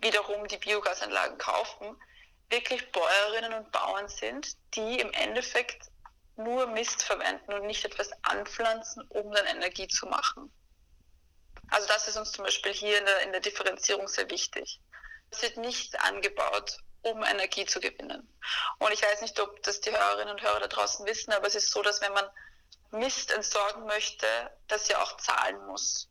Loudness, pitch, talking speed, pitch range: -30 LUFS, 210 Hz, 170 wpm, 200-225 Hz